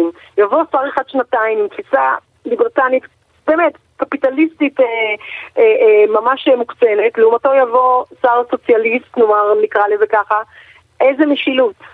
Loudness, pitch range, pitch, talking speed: -14 LUFS, 235-320 Hz, 265 Hz, 120 wpm